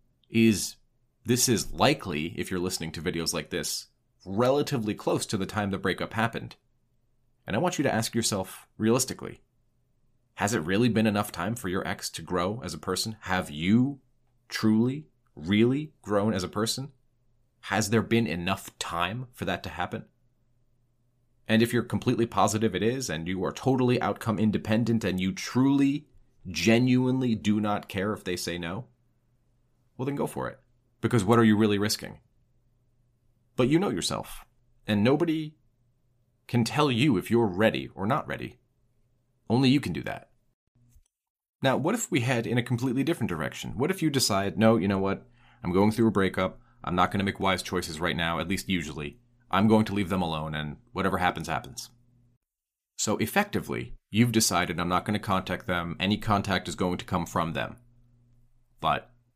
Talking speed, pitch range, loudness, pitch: 180 wpm, 95-120 Hz, -27 LUFS, 115 Hz